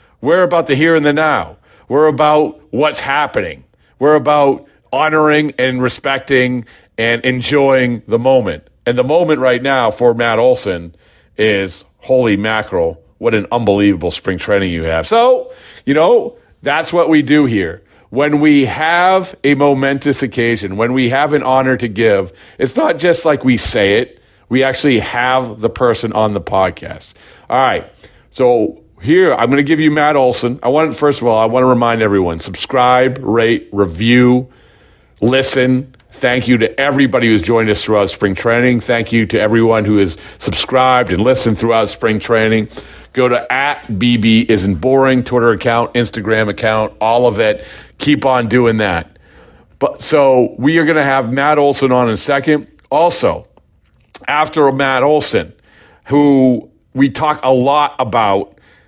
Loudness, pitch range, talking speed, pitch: -13 LUFS, 110-140 Hz, 165 wpm, 125 Hz